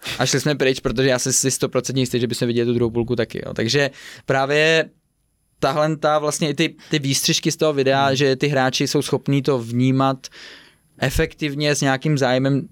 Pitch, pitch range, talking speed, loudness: 135 Hz, 130-150 Hz, 190 wpm, -19 LUFS